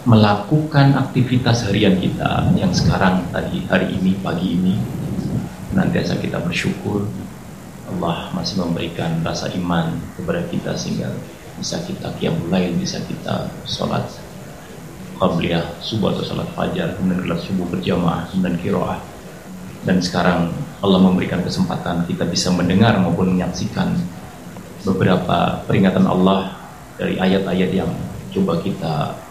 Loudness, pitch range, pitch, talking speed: -19 LUFS, 90-105 Hz, 95 Hz, 120 wpm